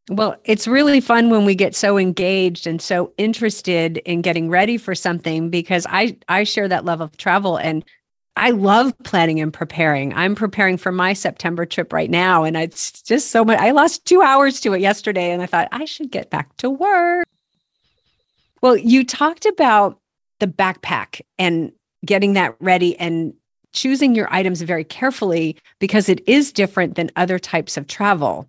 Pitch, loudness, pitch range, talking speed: 190 Hz, -17 LUFS, 170-230 Hz, 180 wpm